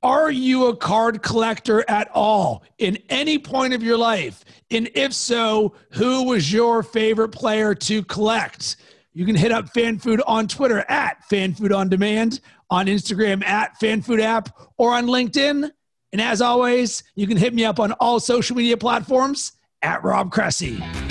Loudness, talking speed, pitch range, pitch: -20 LUFS, 175 wpm, 210-245 Hz, 225 Hz